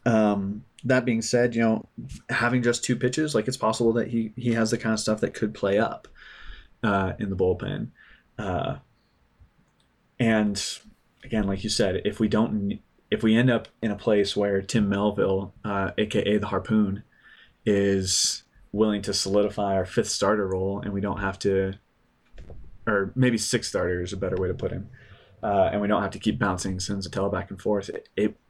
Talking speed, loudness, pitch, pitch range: 190 wpm, -25 LUFS, 105 Hz, 100-115 Hz